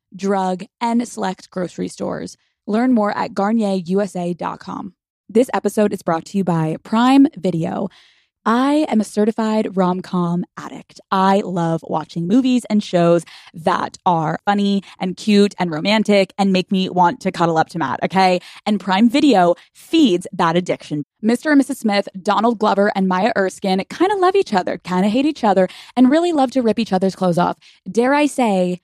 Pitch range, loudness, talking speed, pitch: 185-230 Hz, -18 LUFS, 175 wpm, 200 Hz